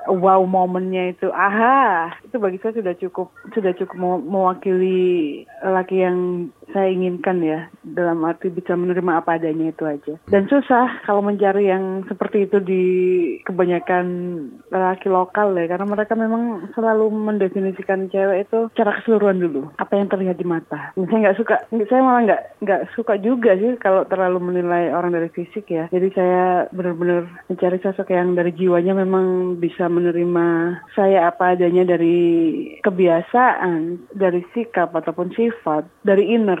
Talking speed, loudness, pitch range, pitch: 150 wpm, -19 LUFS, 175-205 Hz, 185 Hz